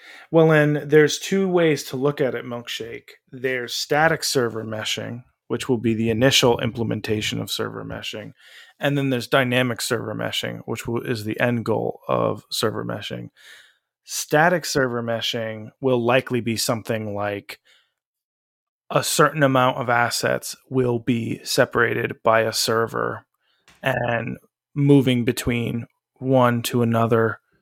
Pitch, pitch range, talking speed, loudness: 120 Hz, 115-135 Hz, 135 wpm, -21 LUFS